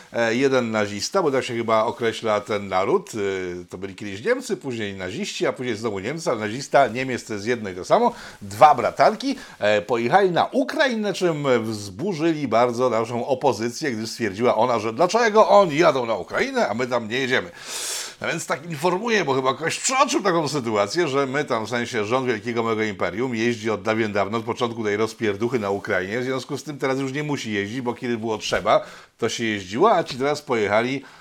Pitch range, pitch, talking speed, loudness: 110-150 Hz, 120 Hz, 190 wpm, -22 LUFS